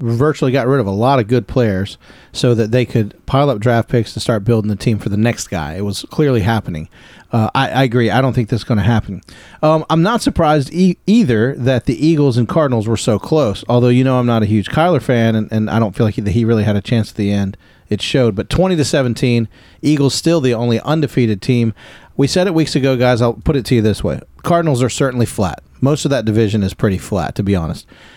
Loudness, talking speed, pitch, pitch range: -15 LUFS, 250 wpm, 120 Hz, 110-140 Hz